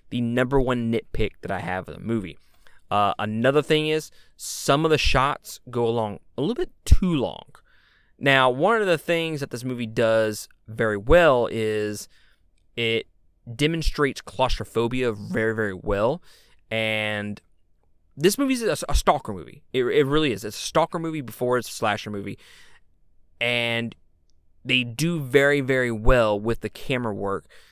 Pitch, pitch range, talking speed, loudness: 115 Hz, 105-135 Hz, 160 wpm, -23 LUFS